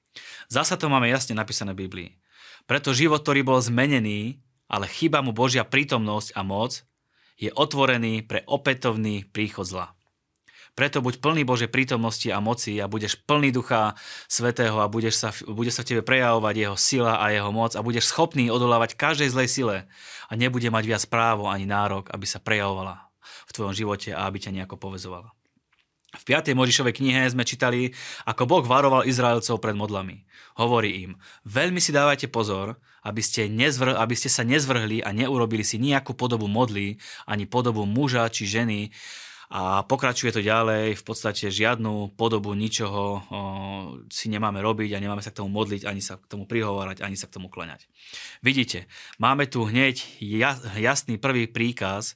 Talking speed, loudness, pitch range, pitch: 170 wpm, -24 LUFS, 105-125 Hz, 115 Hz